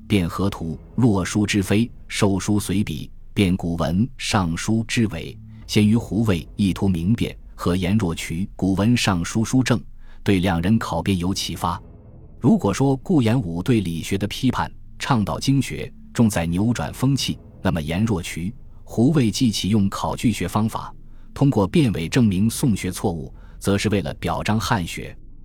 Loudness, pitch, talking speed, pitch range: -21 LUFS, 105 Hz, 235 characters per minute, 90-115 Hz